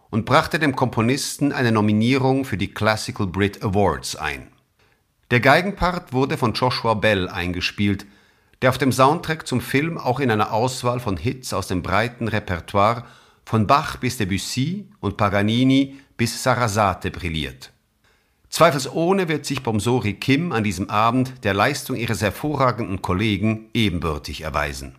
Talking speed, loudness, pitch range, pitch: 140 wpm, -21 LUFS, 100-130 Hz, 115 Hz